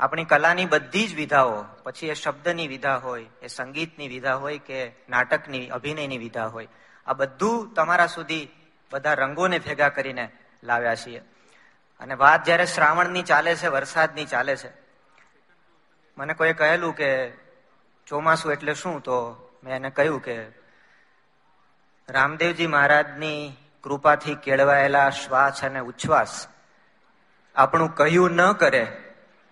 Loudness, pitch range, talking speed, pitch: -22 LUFS, 135-160 Hz, 125 wpm, 145 Hz